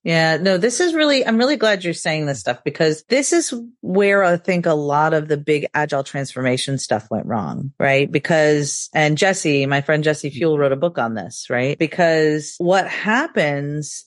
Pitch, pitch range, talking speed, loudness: 155 Hz, 145-190 Hz, 190 wpm, -18 LUFS